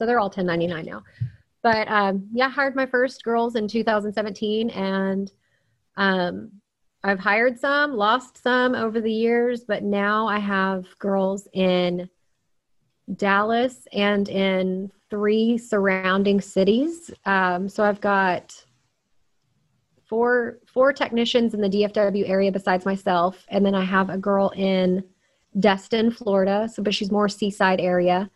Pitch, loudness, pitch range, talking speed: 200 Hz, -22 LUFS, 190-225 Hz, 140 wpm